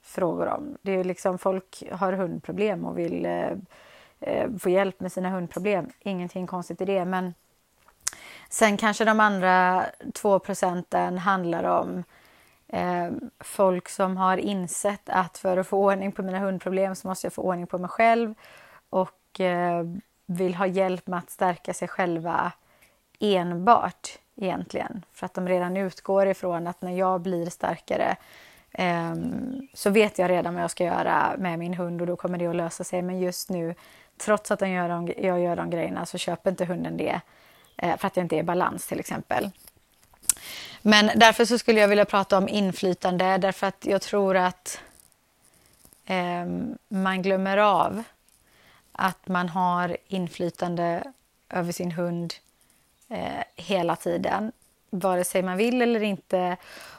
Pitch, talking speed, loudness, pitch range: 185 Hz, 155 wpm, -26 LUFS, 180-195 Hz